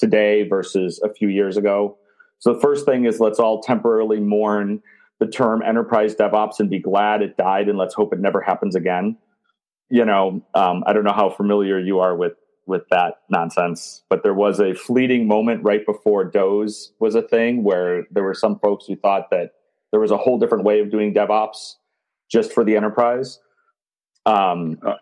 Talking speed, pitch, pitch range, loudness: 190 wpm, 105 Hz, 105-115 Hz, -19 LUFS